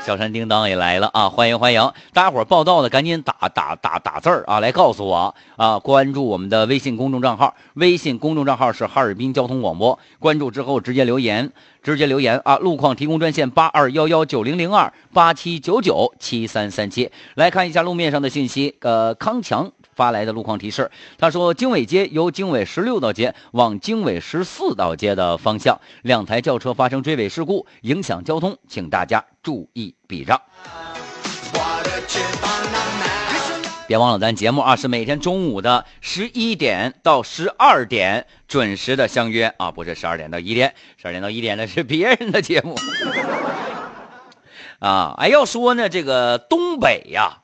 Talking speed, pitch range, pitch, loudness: 270 characters per minute, 120-175 Hz, 140 Hz, -18 LUFS